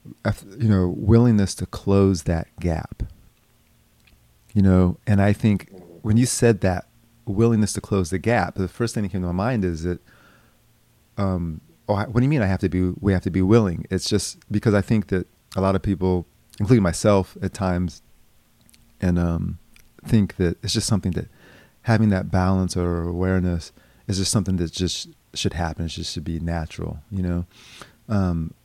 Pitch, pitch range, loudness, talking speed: 95 Hz, 90-110 Hz, -22 LUFS, 185 wpm